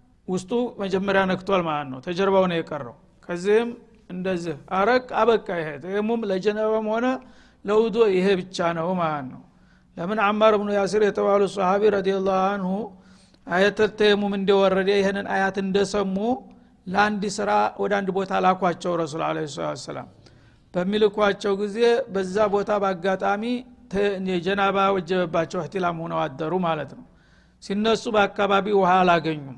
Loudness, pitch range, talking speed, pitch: -23 LUFS, 180-210 Hz, 130 wpm, 195 Hz